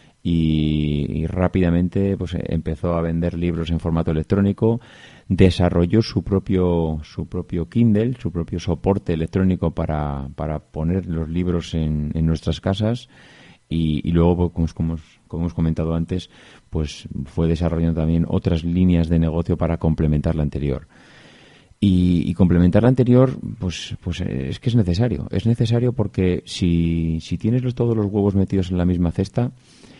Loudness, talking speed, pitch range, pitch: -21 LUFS, 155 wpm, 80-100 Hz, 85 Hz